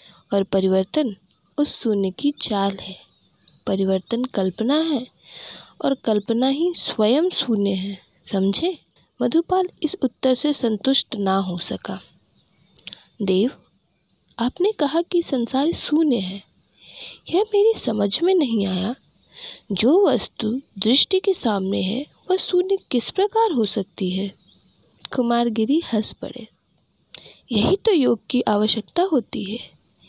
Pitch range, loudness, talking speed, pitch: 200-305 Hz, -20 LUFS, 120 wpm, 240 Hz